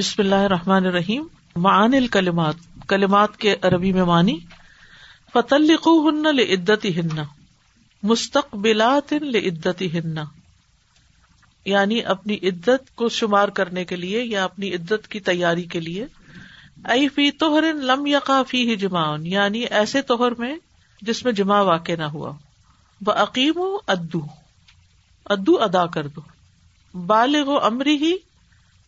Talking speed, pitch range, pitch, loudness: 110 wpm, 170-245 Hz, 200 Hz, -20 LUFS